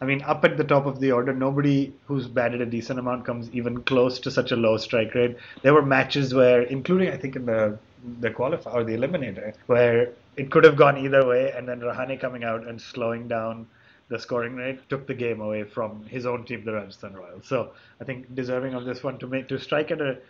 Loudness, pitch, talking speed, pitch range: -24 LUFS, 125 Hz, 235 wpm, 120-135 Hz